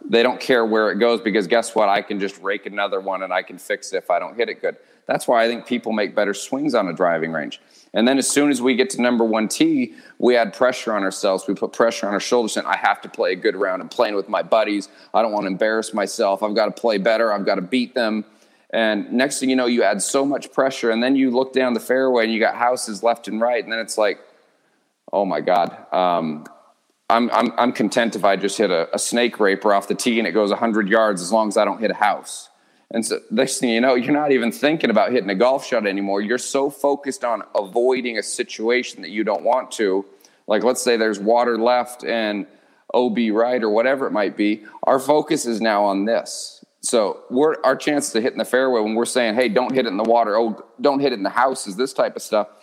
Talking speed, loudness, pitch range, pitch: 260 wpm, -20 LUFS, 110-130 Hz, 120 Hz